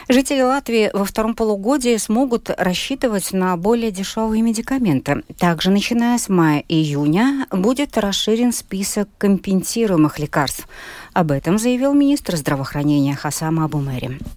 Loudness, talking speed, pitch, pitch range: -18 LUFS, 120 wpm, 200 Hz, 160-235 Hz